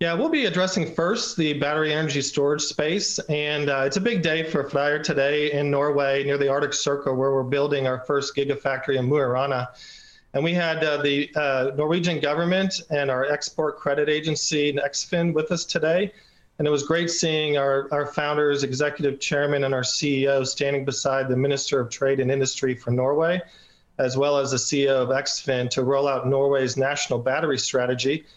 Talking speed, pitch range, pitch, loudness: 185 wpm, 135-155 Hz, 145 Hz, -23 LUFS